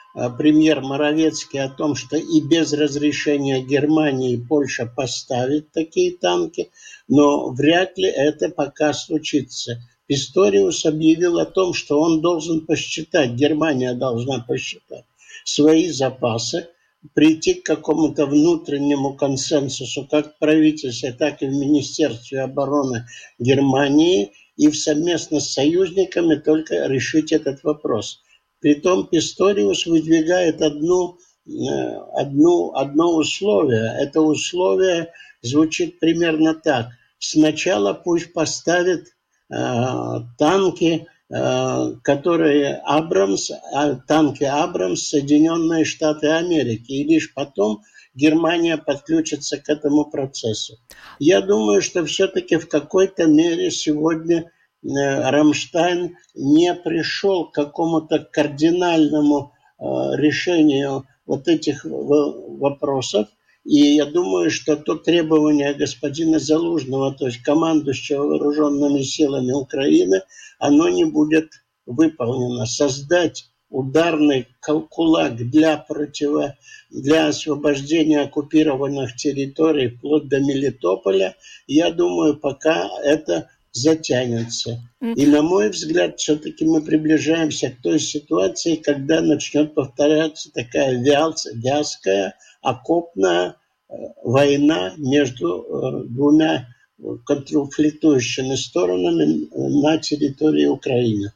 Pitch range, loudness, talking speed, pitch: 140-165 Hz, -19 LUFS, 100 wpm, 150 Hz